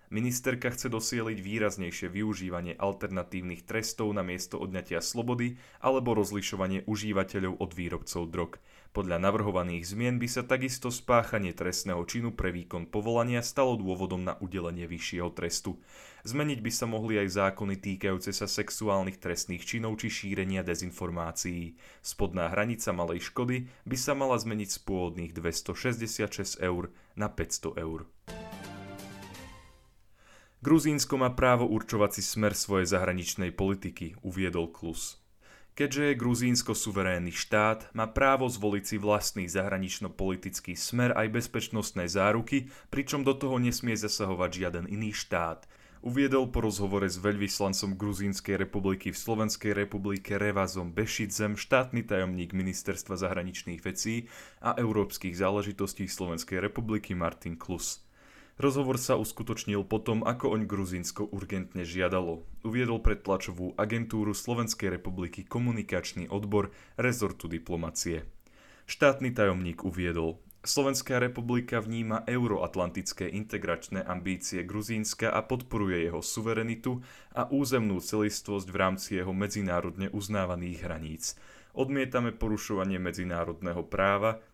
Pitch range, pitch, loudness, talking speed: 90-115 Hz, 100 Hz, -31 LUFS, 120 wpm